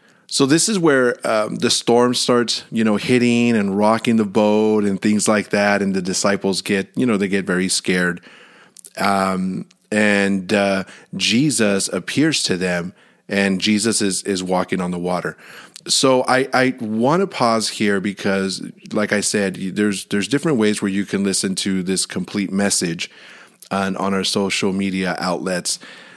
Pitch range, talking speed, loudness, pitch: 95-115 Hz, 165 wpm, -18 LUFS, 100 Hz